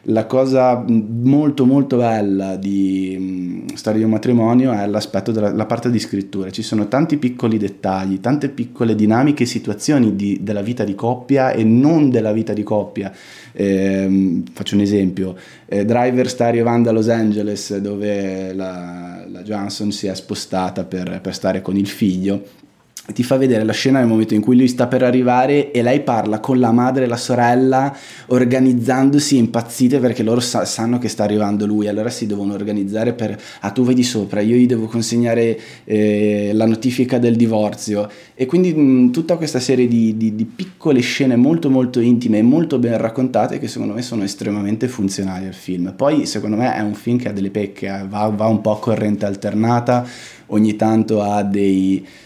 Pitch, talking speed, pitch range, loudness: 110 Hz, 185 wpm, 100-125 Hz, -17 LUFS